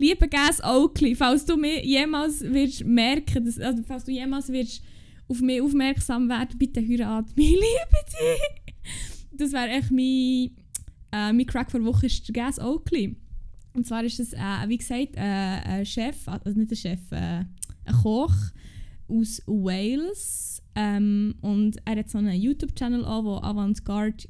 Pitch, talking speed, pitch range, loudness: 240 Hz, 155 wpm, 210-270 Hz, -25 LUFS